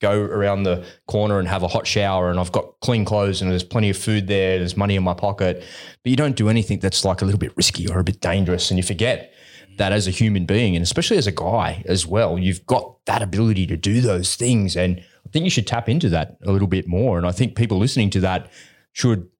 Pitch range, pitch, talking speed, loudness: 90-110 Hz, 100 Hz, 255 wpm, -20 LUFS